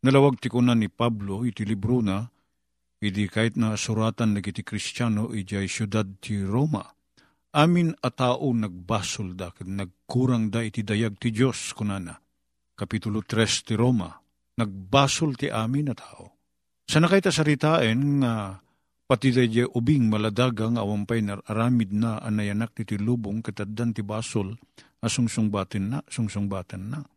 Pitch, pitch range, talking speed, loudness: 110 Hz, 100-125 Hz, 140 wpm, -25 LUFS